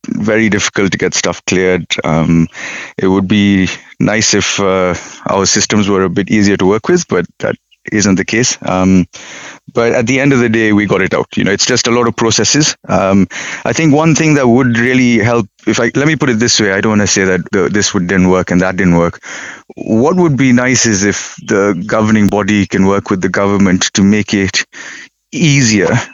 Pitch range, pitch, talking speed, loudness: 95-120 Hz, 105 Hz, 220 wpm, -11 LUFS